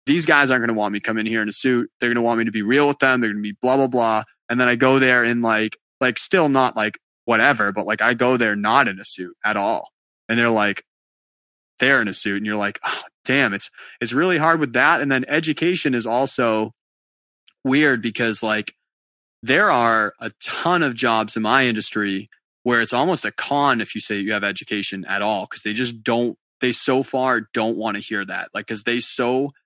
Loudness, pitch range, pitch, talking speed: -20 LUFS, 105-130 Hz, 115 Hz, 240 wpm